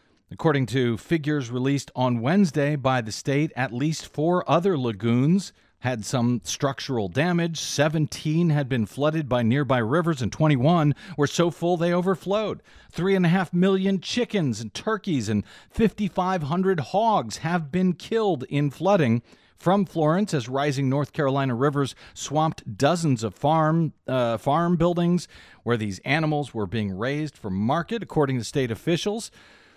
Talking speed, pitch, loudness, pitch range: 150 wpm, 150 Hz, -24 LUFS, 130-175 Hz